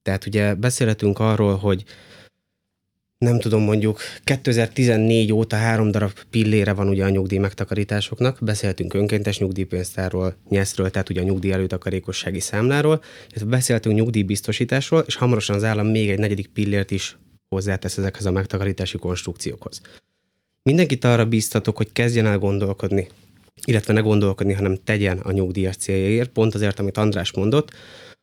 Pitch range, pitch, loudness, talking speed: 95-110 Hz, 105 Hz, -21 LUFS, 140 wpm